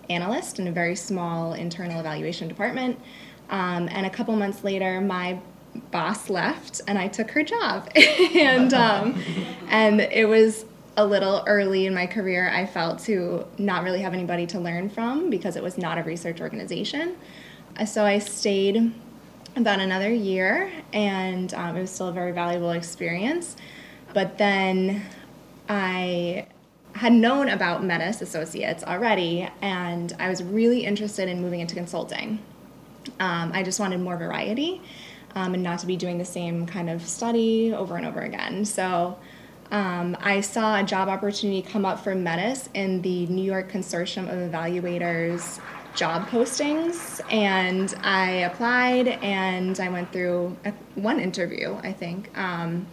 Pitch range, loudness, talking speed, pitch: 180-215 Hz, -24 LUFS, 155 wpm, 190 Hz